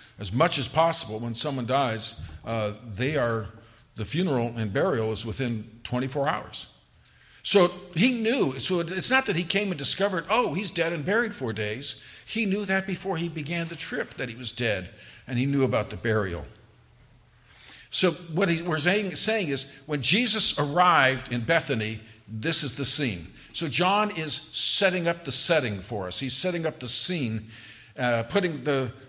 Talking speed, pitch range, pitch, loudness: 175 wpm, 115-175 Hz, 140 Hz, -24 LUFS